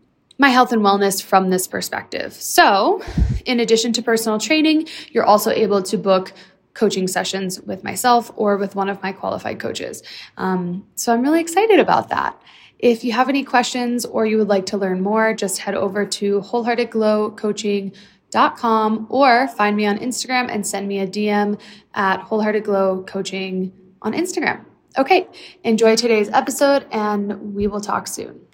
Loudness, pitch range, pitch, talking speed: -18 LUFS, 195-240 Hz, 210 Hz, 160 wpm